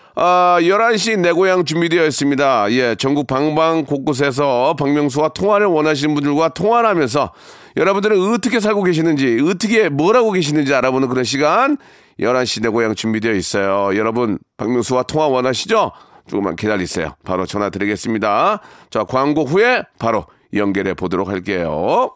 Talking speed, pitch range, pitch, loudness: 355 characters per minute, 115-170 Hz, 145 Hz, -16 LUFS